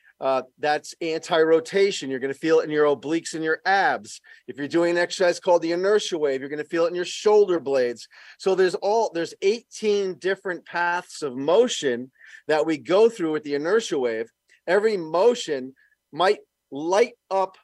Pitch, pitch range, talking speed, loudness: 175 Hz, 155-200 Hz, 185 wpm, -23 LUFS